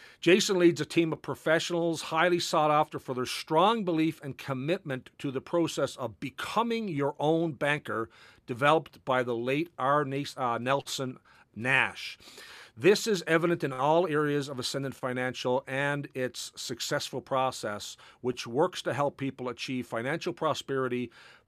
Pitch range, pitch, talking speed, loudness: 130-160 Hz, 145 Hz, 145 wpm, -29 LUFS